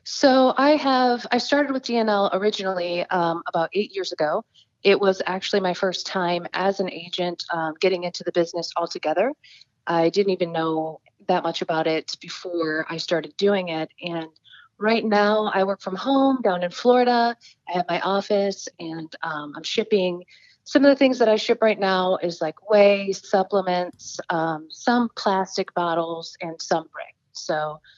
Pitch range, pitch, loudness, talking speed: 170-210 Hz, 185 Hz, -22 LUFS, 170 wpm